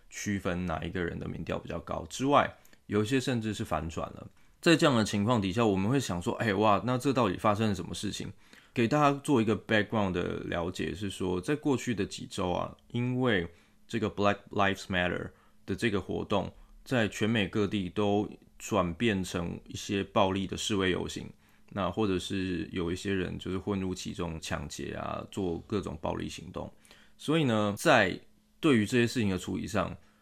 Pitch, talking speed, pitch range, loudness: 100 Hz, 315 characters per minute, 90-110 Hz, -30 LUFS